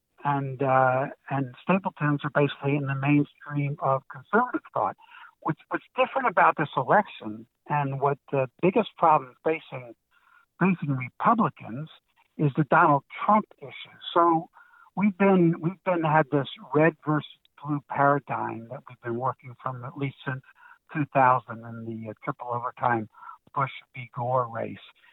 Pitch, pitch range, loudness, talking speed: 145 Hz, 130-170 Hz, -26 LUFS, 140 wpm